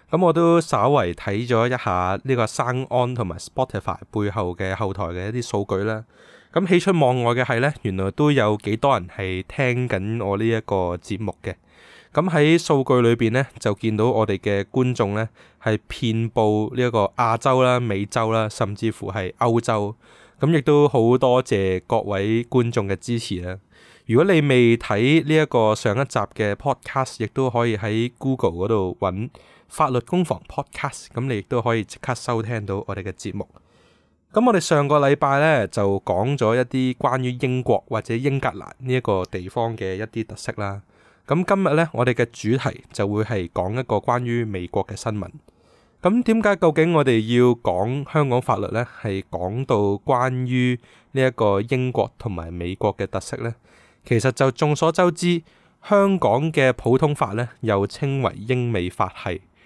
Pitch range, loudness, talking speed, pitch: 105-135 Hz, -21 LUFS, 275 characters per minute, 120 Hz